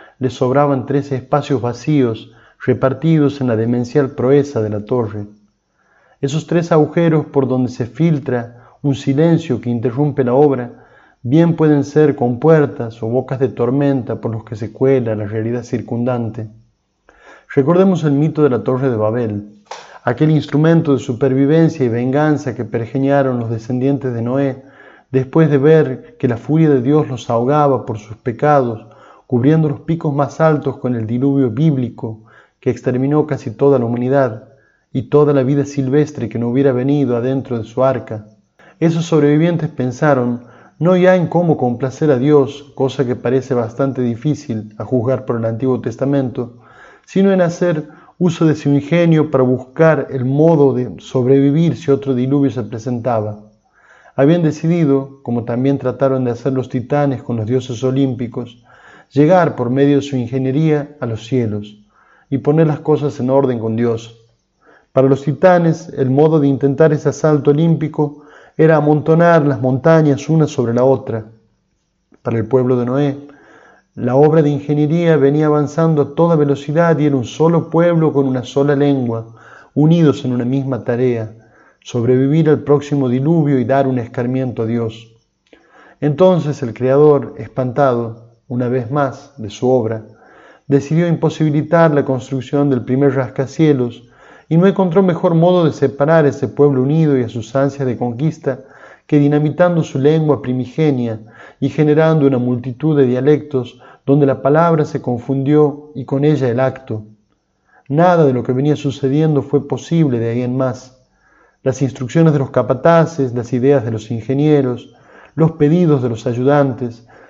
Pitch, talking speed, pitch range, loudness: 135 Hz, 160 wpm, 125-150 Hz, -15 LUFS